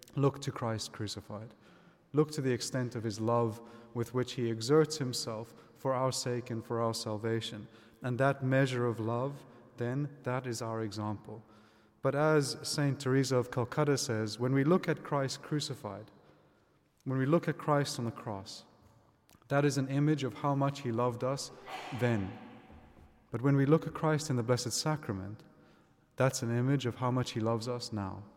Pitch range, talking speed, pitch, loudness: 115-140 Hz, 180 wpm, 125 Hz, -33 LUFS